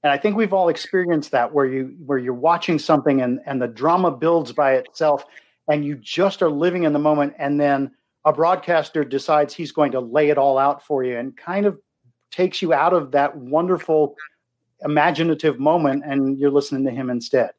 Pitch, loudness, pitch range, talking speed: 150 Hz, -20 LUFS, 135-165 Hz, 200 wpm